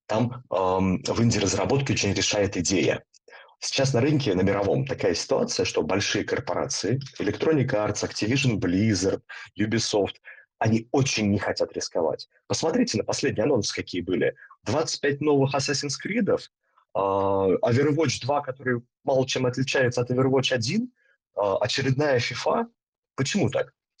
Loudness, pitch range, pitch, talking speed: -25 LUFS, 105-140 Hz, 125 Hz, 130 wpm